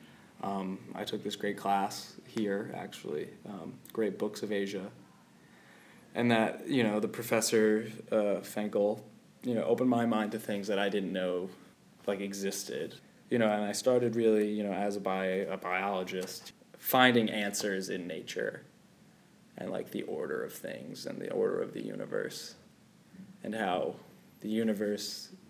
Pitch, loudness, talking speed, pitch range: 105 Hz, -33 LUFS, 160 wpm, 100-120 Hz